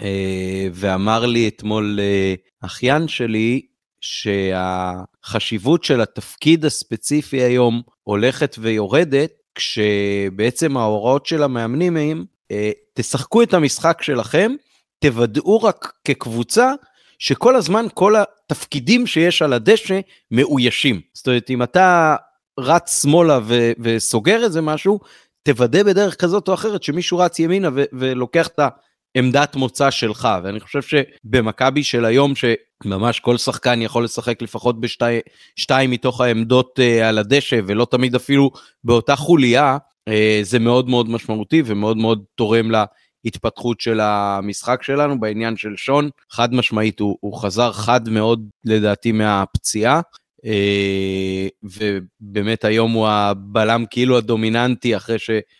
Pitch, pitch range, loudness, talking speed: 120 Hz, 110-145 Hz, -17 LUFS, 120 wpm